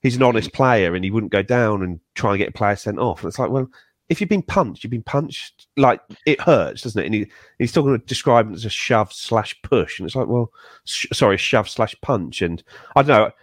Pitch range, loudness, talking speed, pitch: 100-130 Hz, -20 LUFS, 260 wpm, 115 Hz